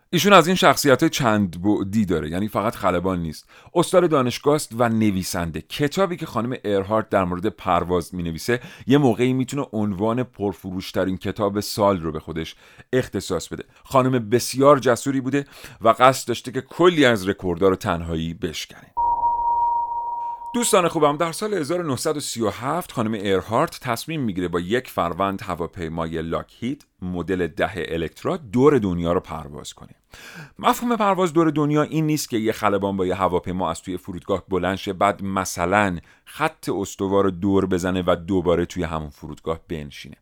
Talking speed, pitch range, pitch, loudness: 150 wpm, 90-140 Hz, 105 Hz, -22 LUFS